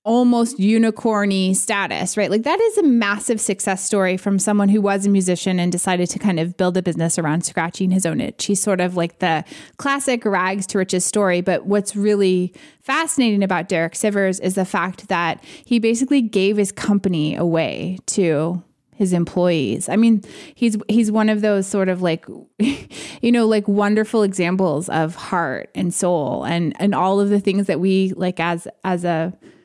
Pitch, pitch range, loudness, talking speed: 195 Hz, 180-215 Hz, -19 LUFS, 185 wpm